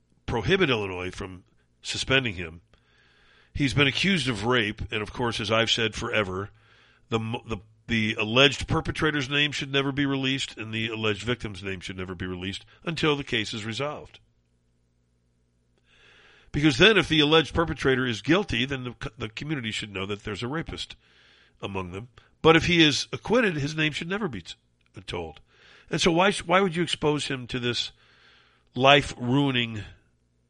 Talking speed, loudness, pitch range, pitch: 165 wpm, -25 LUFS, 100-145 Hz, 120 Hz